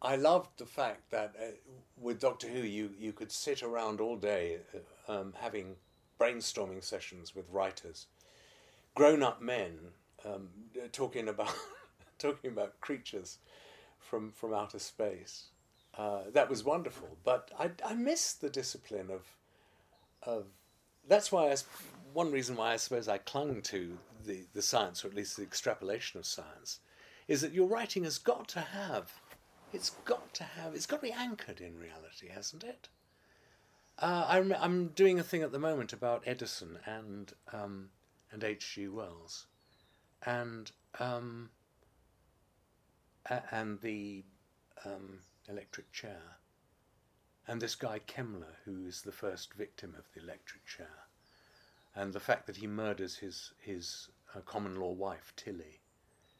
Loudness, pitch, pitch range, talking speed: -37 LUFS, 110 Hz, 100-130 Hz, 150 wpm